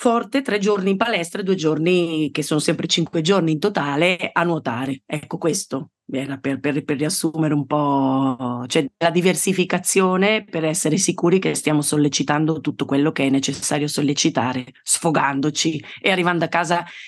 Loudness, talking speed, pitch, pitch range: -20 LUFS, 160 wpm, 155 Hz, 145-175 Hz